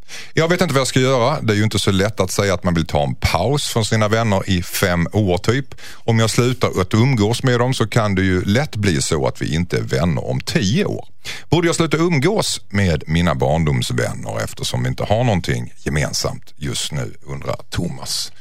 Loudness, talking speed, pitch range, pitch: -18 LUFS, 220 wpm, 90-125 Hz, 105 Hz